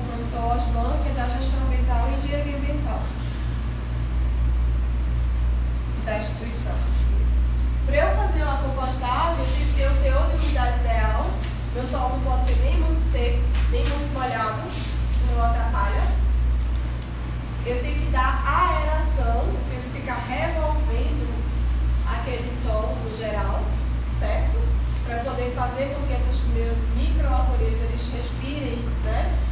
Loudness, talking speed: -25 LUFS, 130 wpm